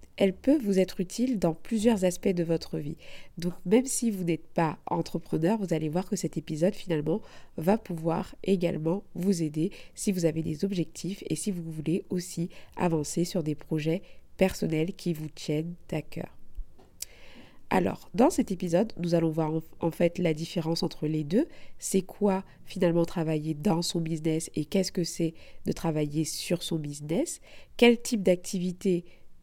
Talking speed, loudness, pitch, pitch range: 170 wpm, -29 LUFS, 175 Hz, 165-195 Hz